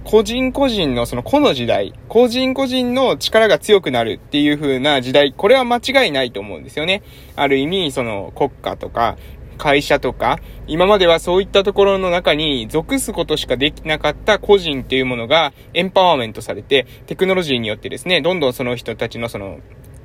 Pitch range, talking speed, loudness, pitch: 125-200 Hz, 395 characters per minute, -16 LUFS, 150 Hz